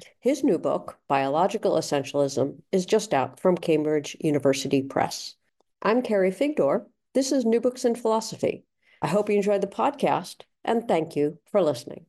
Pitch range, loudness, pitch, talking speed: 145-230 Hz, -25 LUFS, 190 Hz, 160 wpm